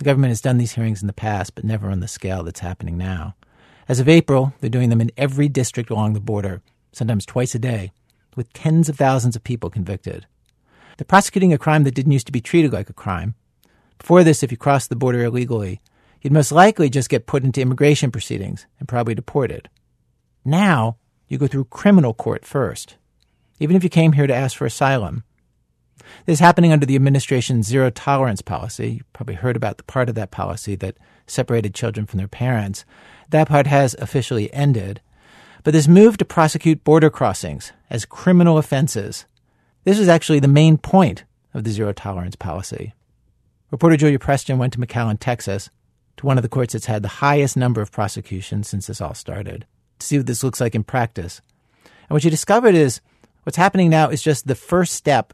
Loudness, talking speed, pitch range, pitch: -18 LUFS, 195 wpm, 110-145 Hz, 125 Hz